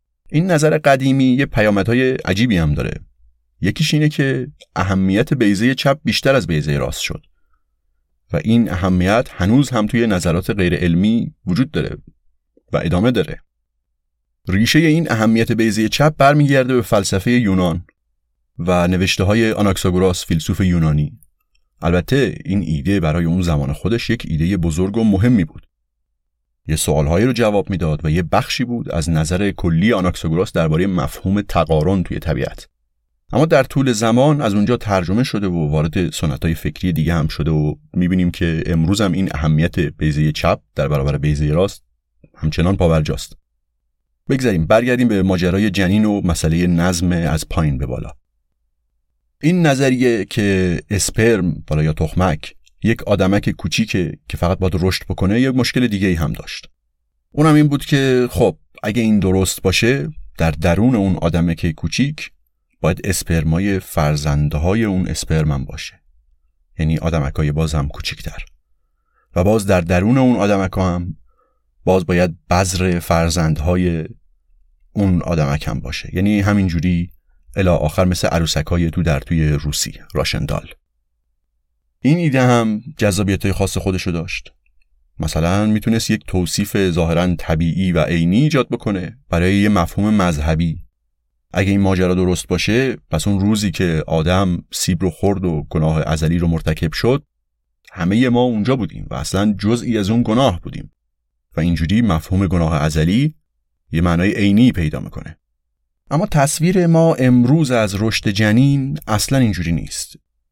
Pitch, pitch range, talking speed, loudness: 90 Hz, 80-105 Hz, 150 wpm, -17 LUFS